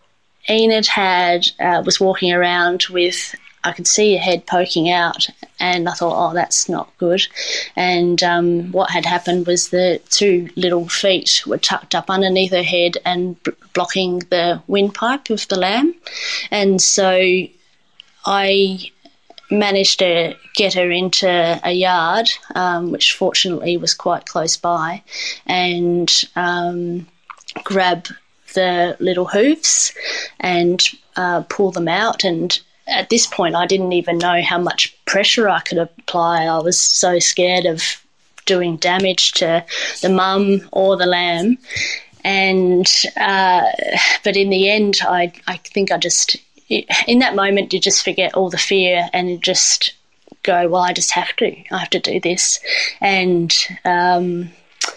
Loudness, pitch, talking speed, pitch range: -16 LUFS, 180 Hz, 145 wpm, 175-195 Hz